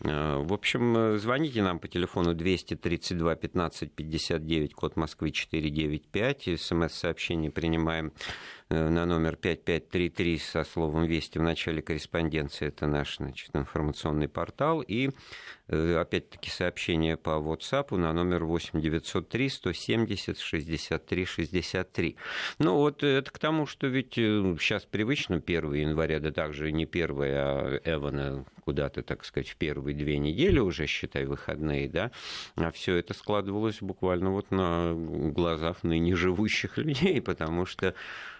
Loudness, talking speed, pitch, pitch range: -30 LUFS, 120 wpm, 85 Hz, 80-100 Hz